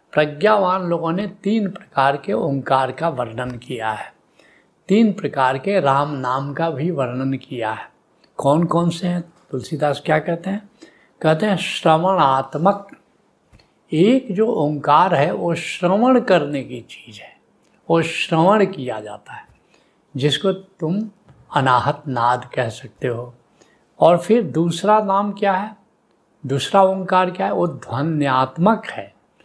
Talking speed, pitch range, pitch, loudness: 135 wpm, 135-195 Hz, 165 Hz, -19 LUFS